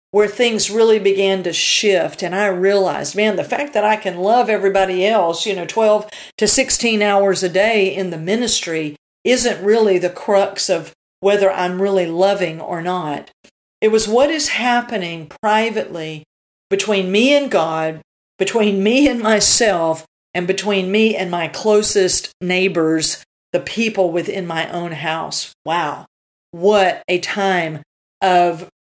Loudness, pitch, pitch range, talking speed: -16 LUFS, 195 Hz, 175-215 Hz, 150 wpm